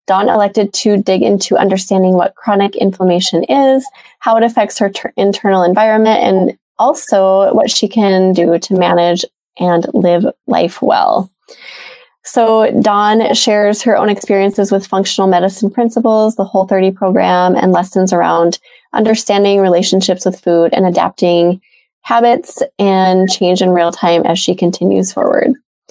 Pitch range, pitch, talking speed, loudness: 180-215 Hz, 195 Hz, 140 wpm, -11 LUFS